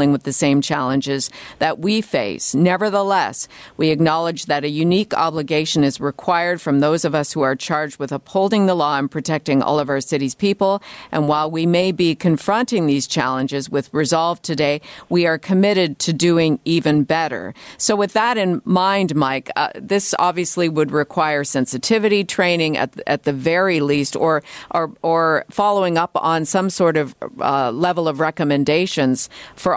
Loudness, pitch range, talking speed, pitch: -18 LUFS, 145-180 Hz, 170 wpm, 160 Hz